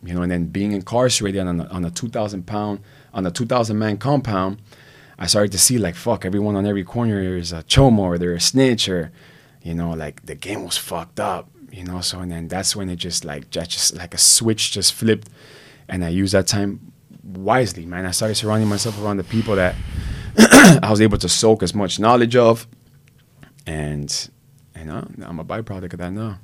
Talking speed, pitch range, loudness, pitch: 210 wpm, 90-115 Hz, -18 LUFS, 100 Hz